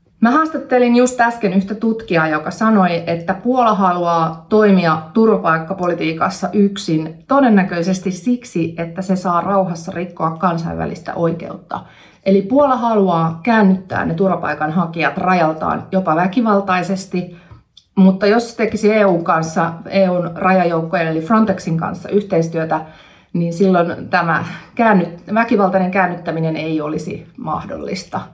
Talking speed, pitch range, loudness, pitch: 110 wpm, 170-205 Hz, -16 LUFS, 185 Hz